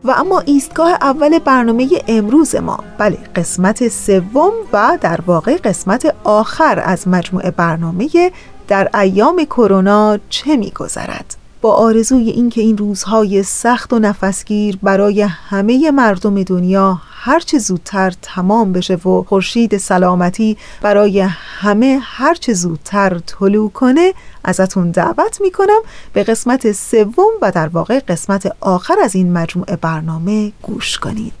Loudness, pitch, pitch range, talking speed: -13 LUFS, 210 Hz, 190-255 Hz, 125 wpm